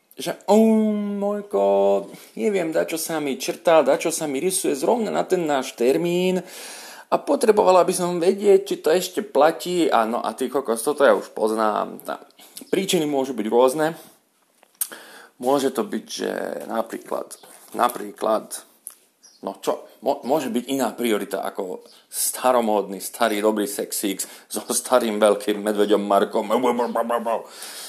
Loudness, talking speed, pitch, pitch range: -22 LUFS, 140 wpm, 130 Hz, 110-180 Hz